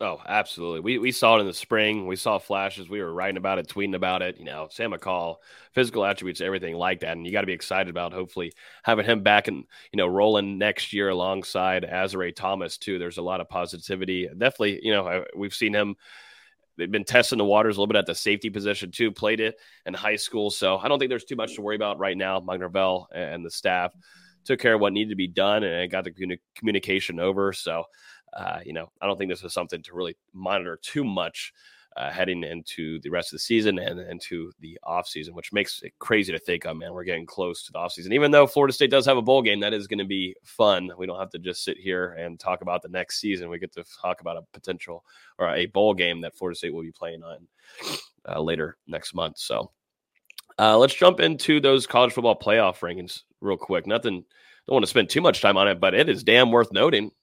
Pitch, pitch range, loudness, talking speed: 95 Hz, 90-105 Hz, -24 LUFS, 240 wpm